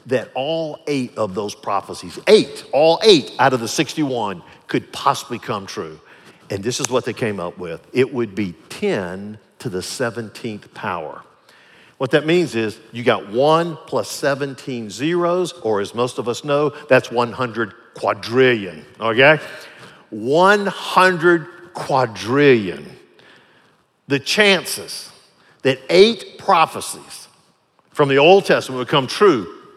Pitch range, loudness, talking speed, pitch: 120-170 Hz, -18 LUFS, 135 wpm, 135 Hz